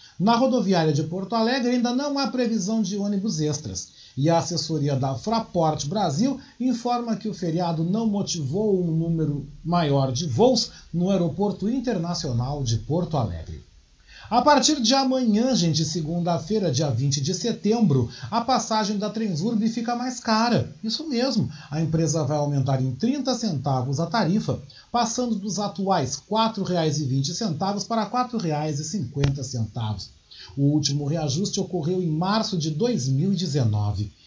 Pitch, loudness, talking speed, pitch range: 180 Hz, -24 LUFS, 140 wpm, 150-225 Hz